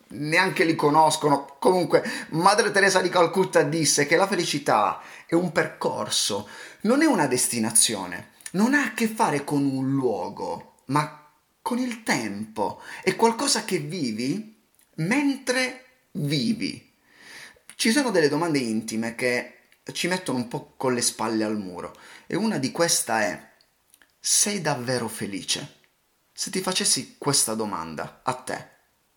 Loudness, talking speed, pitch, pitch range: -23 LUFS, 140 wpm, 165 Hz, 130-220 Hz